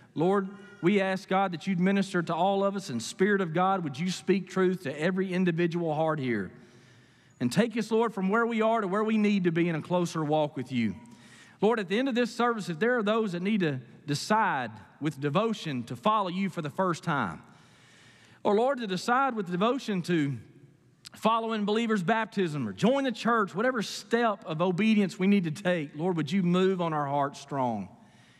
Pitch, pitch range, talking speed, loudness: 190 Hz, 160-215 Hz, 210 wpm, -28 LUFS